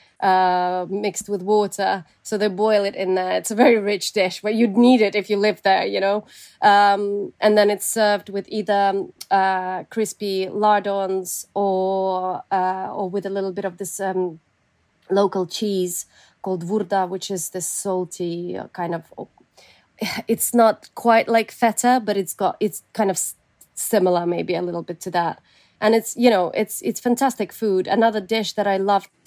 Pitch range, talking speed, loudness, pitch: 185-215 Hz, 180 wpm, -21 LUFS, 200 Hz